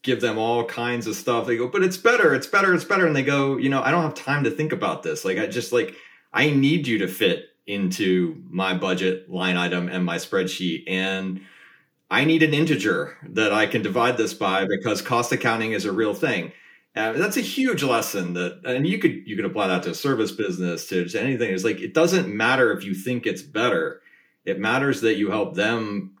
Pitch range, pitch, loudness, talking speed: 95-155 Hz, 120 Hz, -22 LUFS, 225 wpm